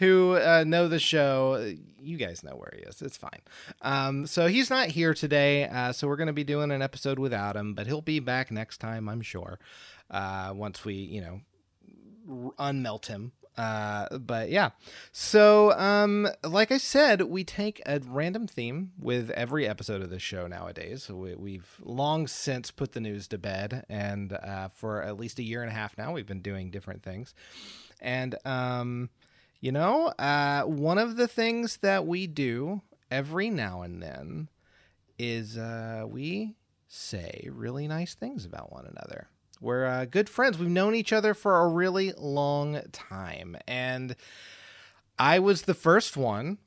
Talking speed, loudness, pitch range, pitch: 175 wpm, -28 LUFS, 110-175 Hz, 135 Hz